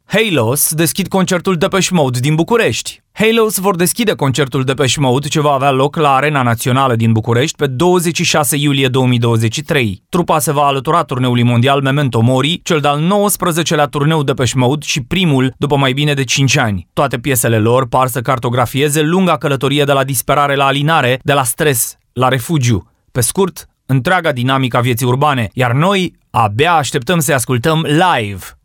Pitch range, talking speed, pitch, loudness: 130-160 Hz, 170 wpm, 145 Hz, -13 LUFS